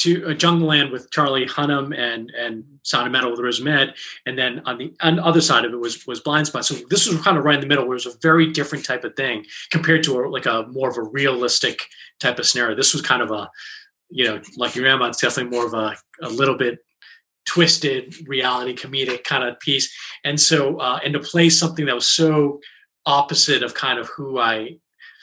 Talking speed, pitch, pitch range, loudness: 235 wpm, 140 Hz, 125-160 Hz, -19 LUFS